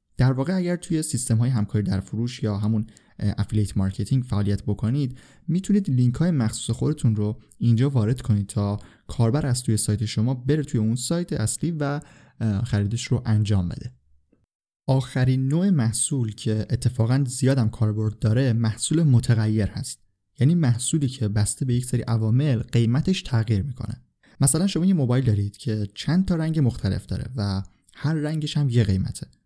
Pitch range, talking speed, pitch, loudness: 105-140 Hz, 160 wpm, 120 Hz, -23 LUFS